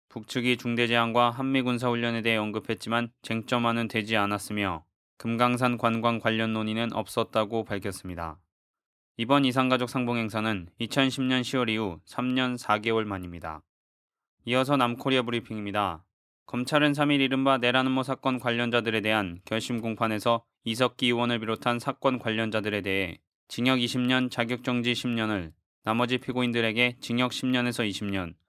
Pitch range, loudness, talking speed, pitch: 110-125 Hz, -27 LUFS, 325 characters per minute, 115 Hz